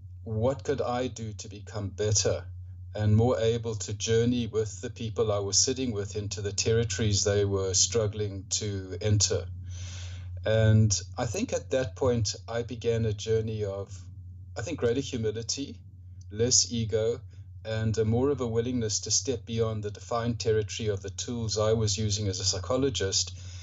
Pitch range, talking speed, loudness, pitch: 95-115 Hz, 165 wpm, -28 LUFS, 105 Hz